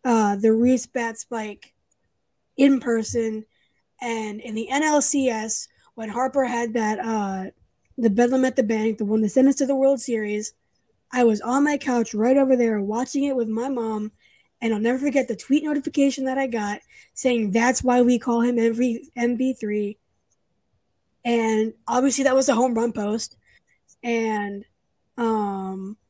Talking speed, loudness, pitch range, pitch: 165 wpm, -22 LUFS, 220-260 Hz, 235 Hz